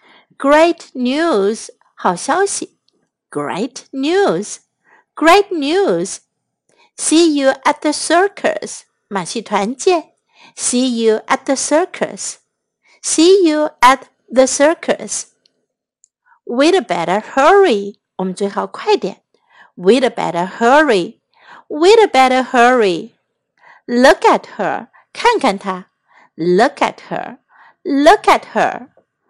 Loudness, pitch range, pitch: -14 LUFS, 240-350 Hz, 295 Hz